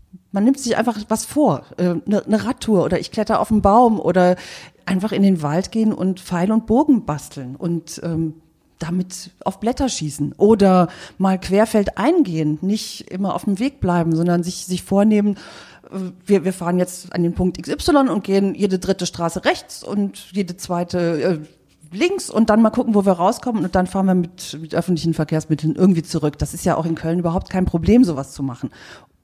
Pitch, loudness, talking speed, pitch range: 185 Hz, -19 LUFS, 185 wpm, 170-210 Hz